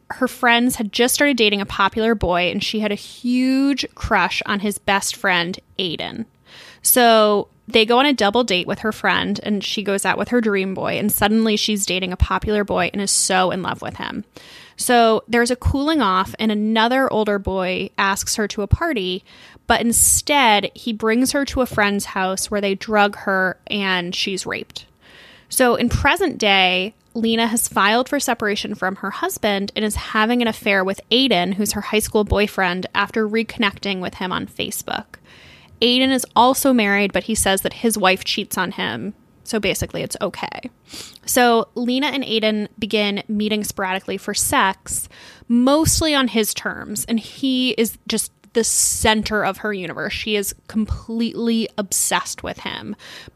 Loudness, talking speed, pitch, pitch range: -19 LUFS, 175 wpm, 215 Hz, 200-235 Hz